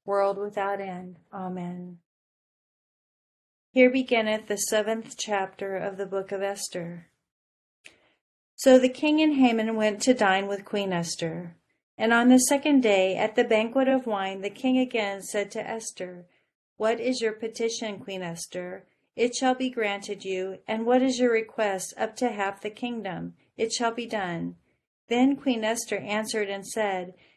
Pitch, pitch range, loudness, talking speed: 210 Hz, 190-235 Hz, -26 LUFS, 160 wpm